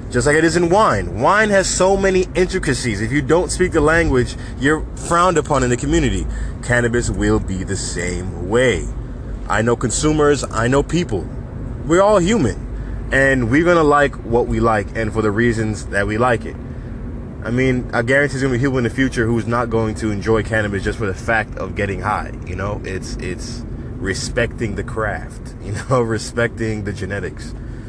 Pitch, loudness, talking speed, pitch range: 120 Hz, -18 LUFS, 195 wpm, 110-140 Hz